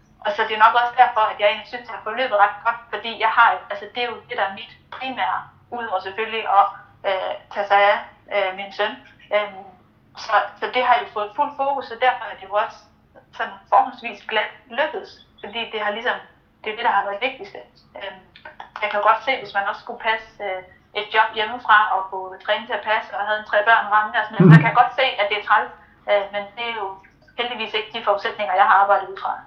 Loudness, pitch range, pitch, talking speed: -20 LUFS, 205-230 Hz, 215 Hz, 240 wpm